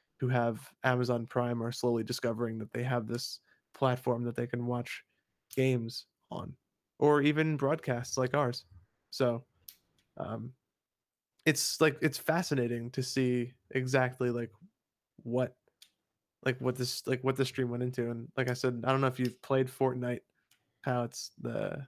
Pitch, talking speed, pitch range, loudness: 125 Hz, 155 wpm, 120-130 Hz, -32 LUFS